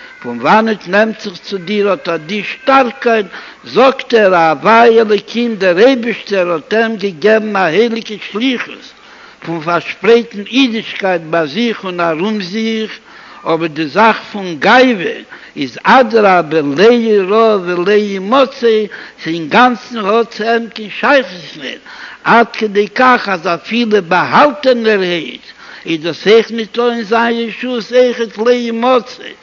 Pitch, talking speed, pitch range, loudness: 220 Hz, 155 wpm, 190-235 Hz, -12 LUFS